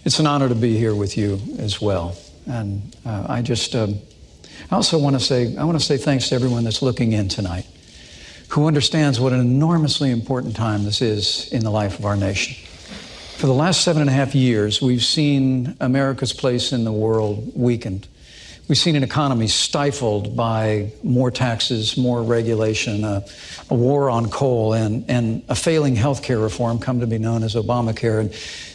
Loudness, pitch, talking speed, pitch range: -19 LUFS, 120 Hz, 185 wpm, 110-135 Hz